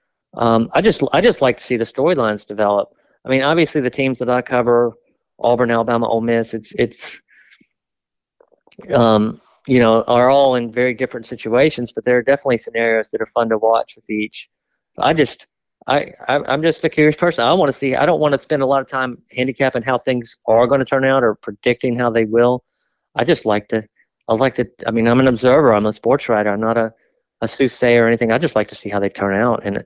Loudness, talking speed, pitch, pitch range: -17 LUFS, 225 wpm, 120 Hz, 115-130 Hz